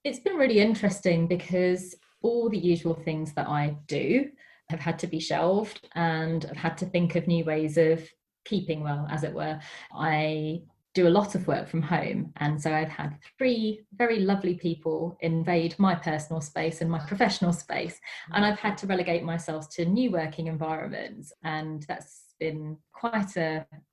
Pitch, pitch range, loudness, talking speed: 170 Hz, 160-195 Hz, -28 LUFS, 175 wpm